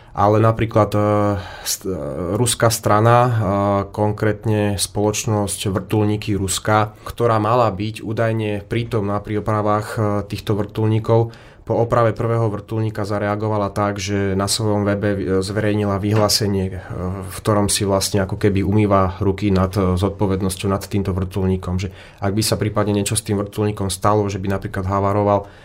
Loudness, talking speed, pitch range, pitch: -19 LUFS, 145 wpm, 100-110 Hz, 105 Hz